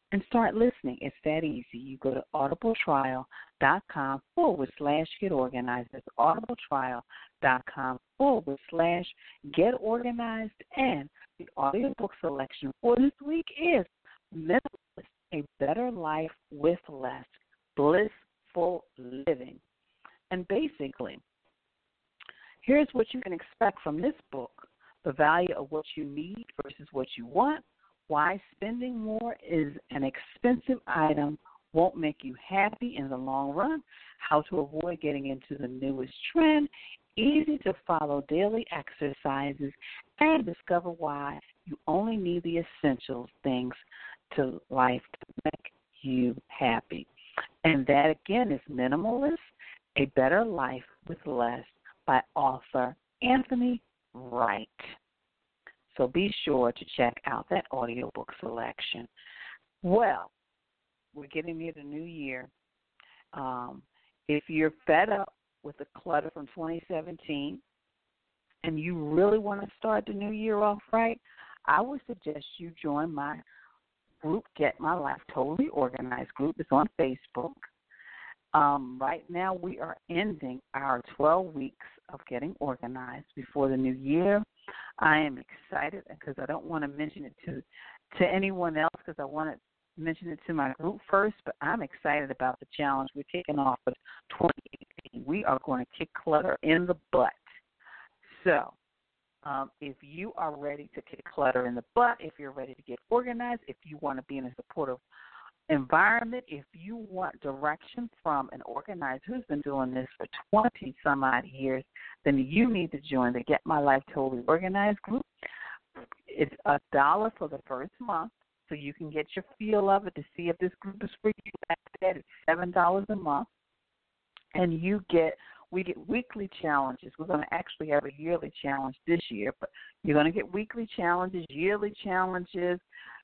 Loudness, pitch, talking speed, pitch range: -30 LUFS, 155 Hz, 150 wpm, 140-195 Hz